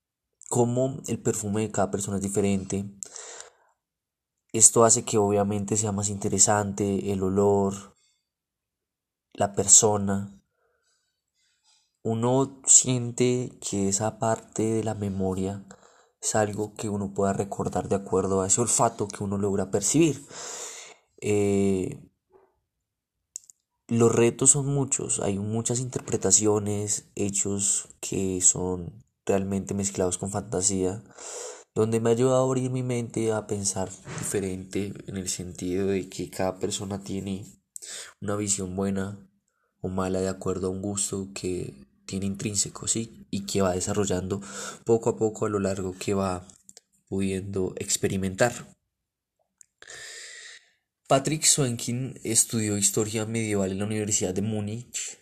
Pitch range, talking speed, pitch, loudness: 95-115 Hz, 125 wpm, 100 Hz, -25 LUFS